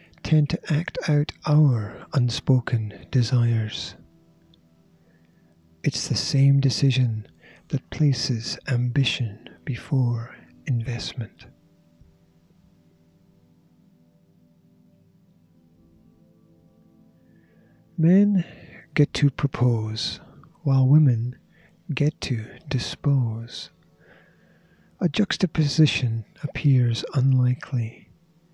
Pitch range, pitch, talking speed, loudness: 110-150 Hz, 130 Hz, 60 wpm, -23 LUFS